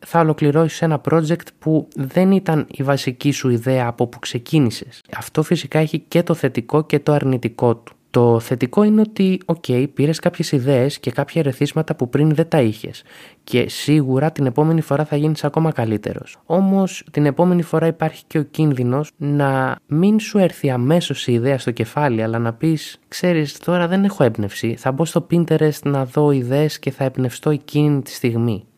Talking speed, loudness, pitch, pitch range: 185 wpm, -18 LUFS, 150 Hz, 130-165 Hz